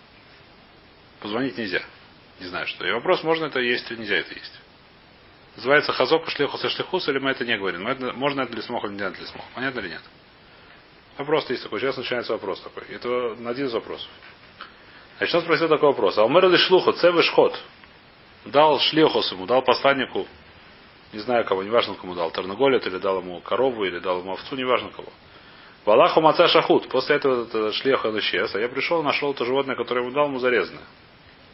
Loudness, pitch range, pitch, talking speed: -22 LUFS, 120-165 Hz, 135 Hz, 190 wpm